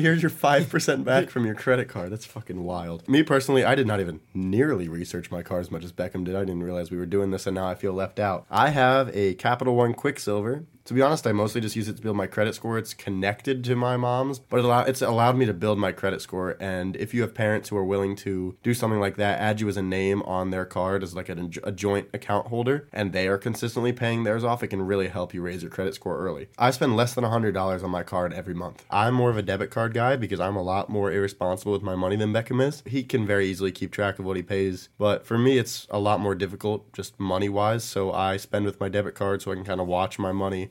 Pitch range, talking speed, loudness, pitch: 95-120 Hz, 265 wpm, -26 LUFS, 100 Hz